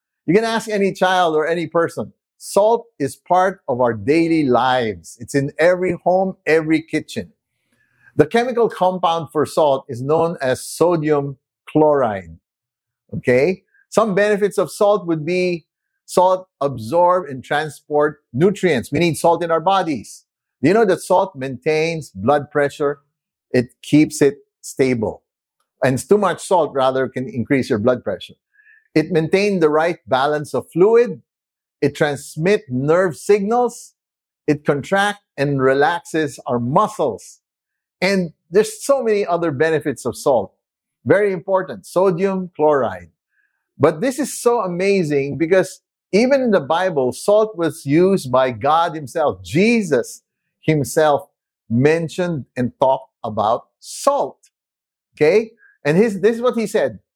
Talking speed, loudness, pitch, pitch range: 140 wpm, -18 LUFS, 165 Hz, 140-195 Hz